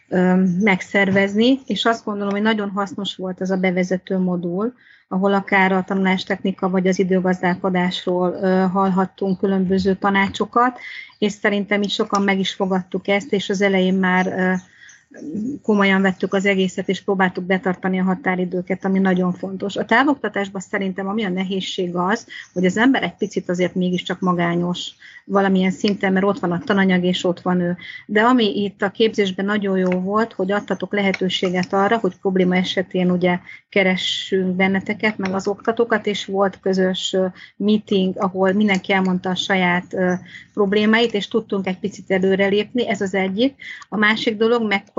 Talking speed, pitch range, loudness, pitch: 155 wpm, 185-205 Hz, -19 LUFS, 195 Hz